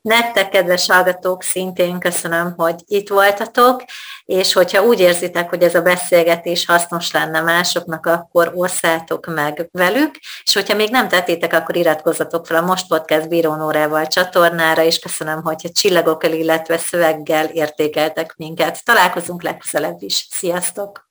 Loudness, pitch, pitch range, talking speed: -16 LUFS, 170 Hz, 160-185 Hz, 140 wpm